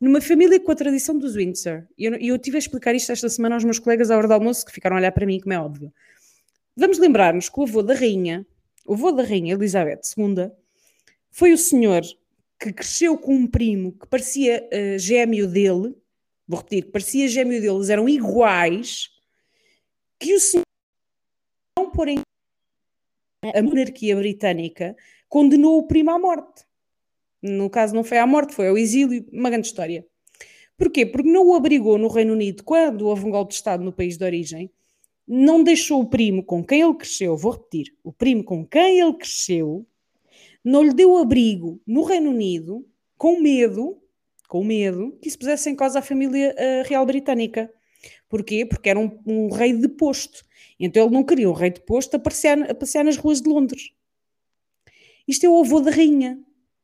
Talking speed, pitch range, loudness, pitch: 185 wpm, 200-290 Hz, -19 LUFS, 240 Hz